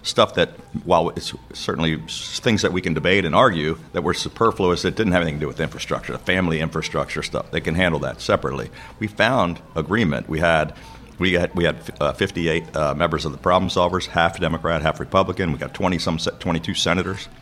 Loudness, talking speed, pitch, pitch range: -21 LUFS, 205 wpm, 85 Hz, 80-90 Hz